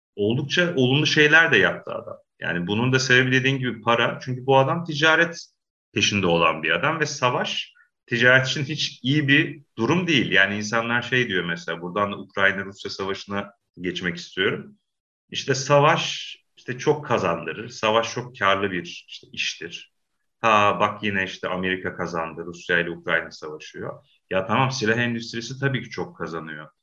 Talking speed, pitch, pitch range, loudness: 155 wpm, 115 Hz, 95-135 Hz, -22 LUFS